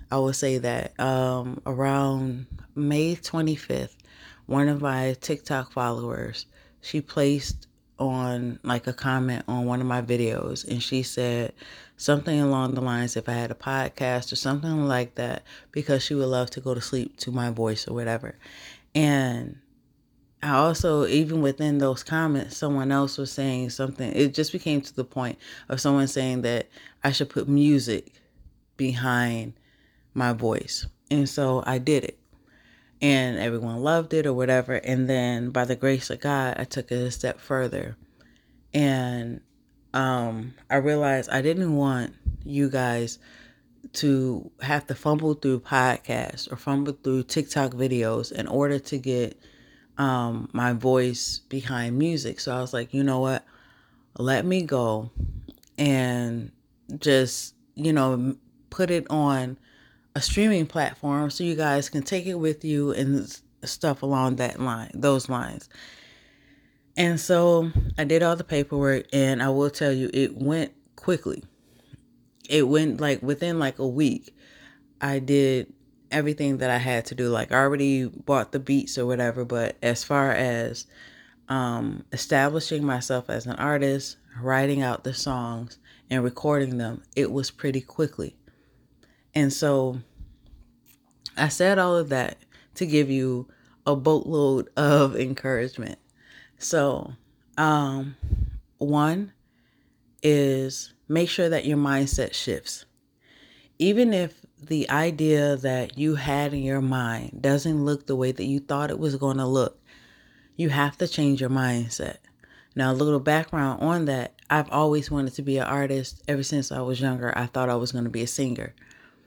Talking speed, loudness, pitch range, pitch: 155 wpm, -25 LUFS, 125-145 Hz, 135 Hz